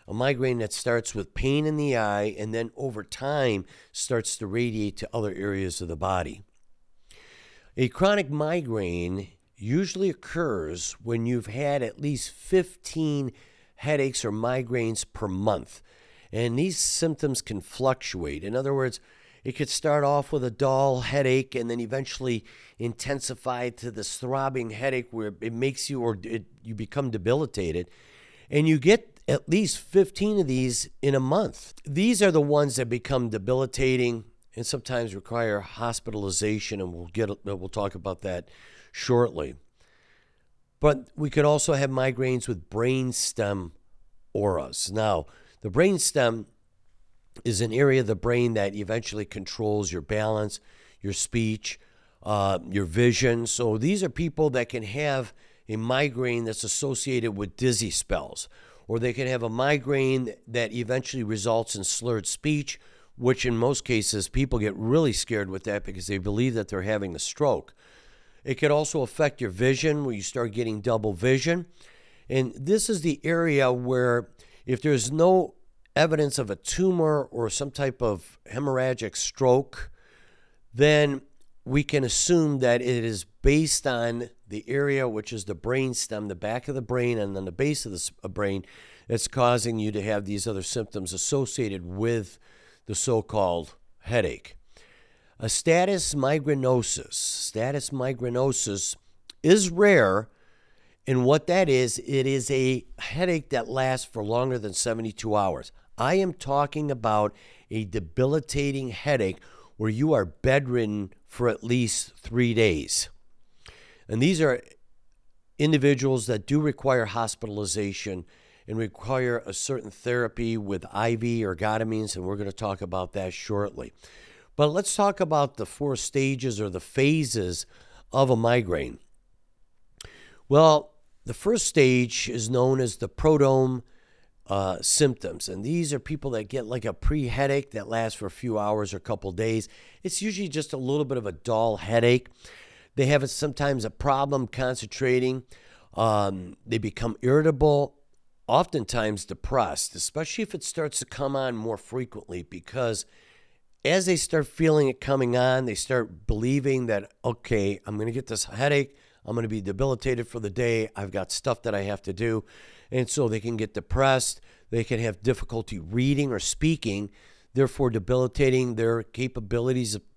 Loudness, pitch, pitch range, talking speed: -26 LUFS, 120 Hz, 105-135 Hz, 155 wpm